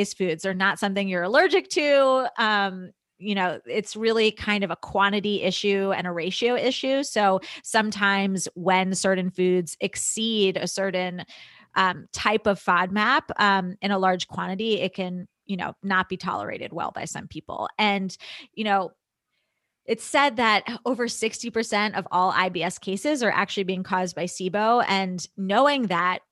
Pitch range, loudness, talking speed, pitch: 185-225 Hz, -24 LUFS, 160 wpm, 200 Hz